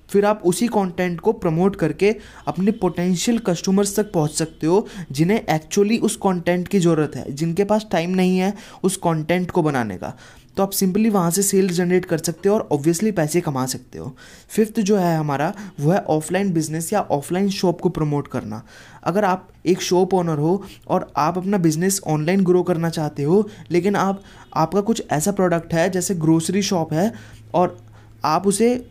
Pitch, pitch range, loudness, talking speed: 180 Hz, 160-200 Hz, -20 LUFS, 185 wpm